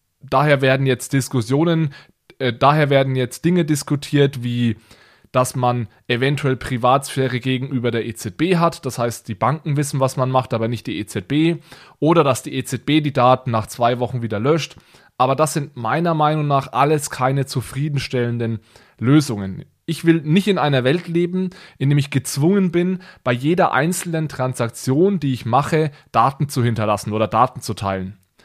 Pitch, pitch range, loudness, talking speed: 135 Hz, 120-155 Hz, -19 LUFS, 165 wpm